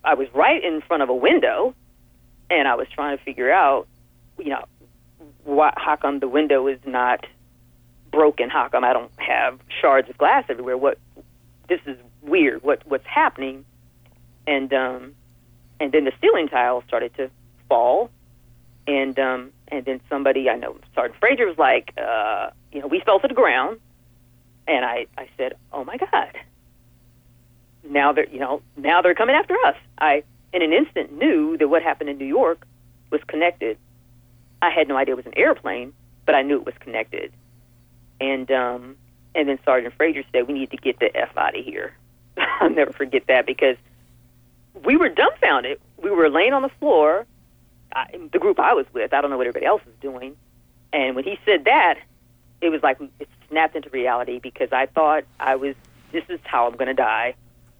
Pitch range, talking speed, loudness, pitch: 120-155 Hz, 185 wpm, -20 LUFS, 130 Hz